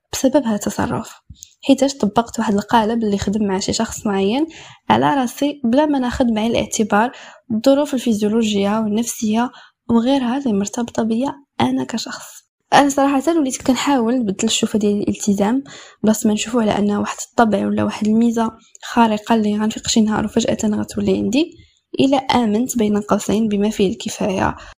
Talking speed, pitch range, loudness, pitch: 150 wpm, 210-265 Hz, -18 LUFS, 230 Hz